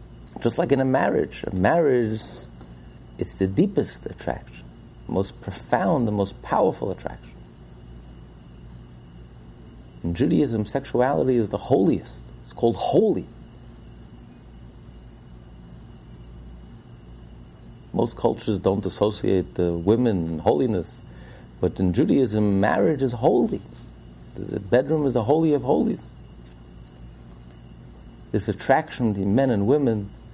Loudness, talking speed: -23 LUFS, 105 wpm